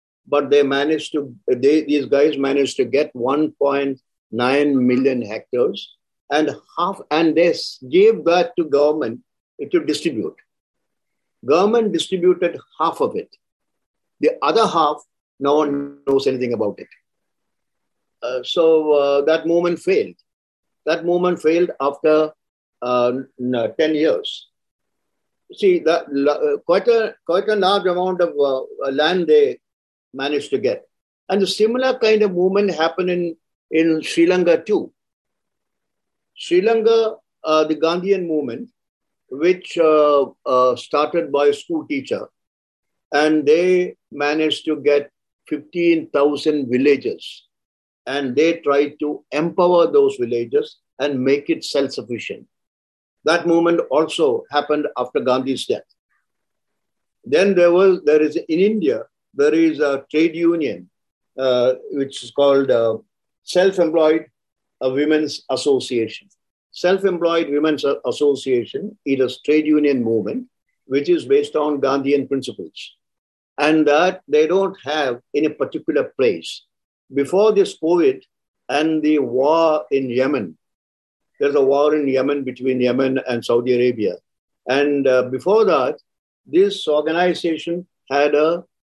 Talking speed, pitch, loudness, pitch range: 130 wpm, 155 Hz, -18 LUFS, 140-185 Hz